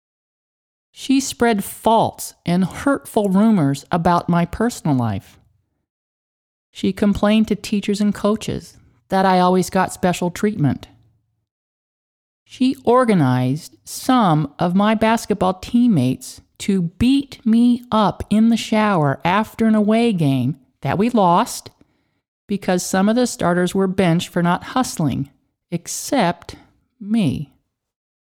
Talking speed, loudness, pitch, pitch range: 115 wpm, -18 LUFS, 190 Hz, 150-220 Hz